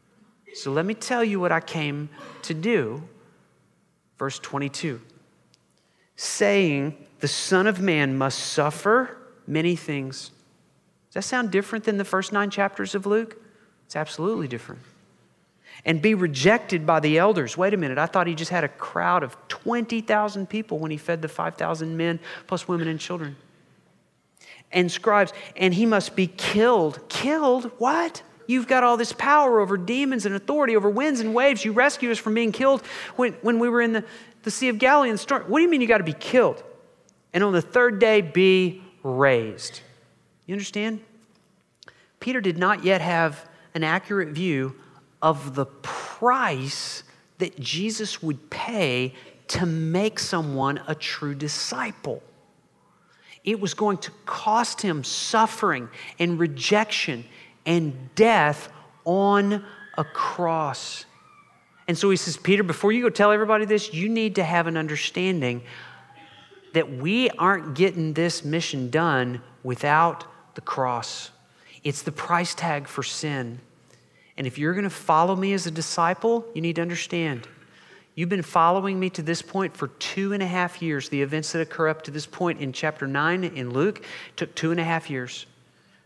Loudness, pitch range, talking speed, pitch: -24 LUFS, 155-215 Hz, 165 wpm, 180 Hz